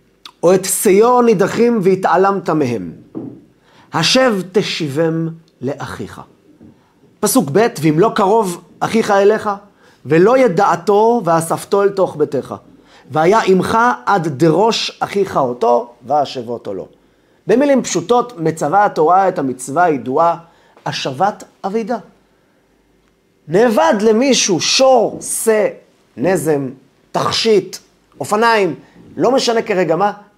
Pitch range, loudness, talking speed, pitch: 165-225 Hz, -14 LUFS, 100 wpm, 195 Hz